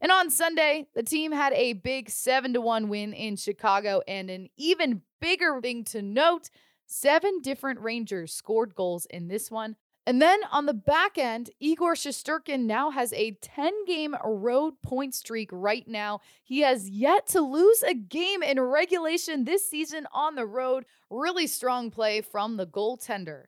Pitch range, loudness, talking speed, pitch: 215-310 Hz, -27 LUFS, 170 wpm, 255 Hz